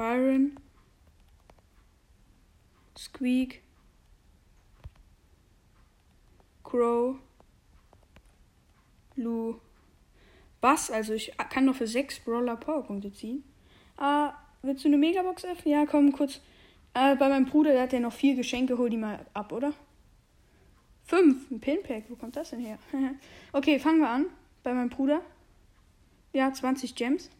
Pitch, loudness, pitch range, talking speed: 255 Hz, -28 LUFS, 220-285 Hz, 125 wpm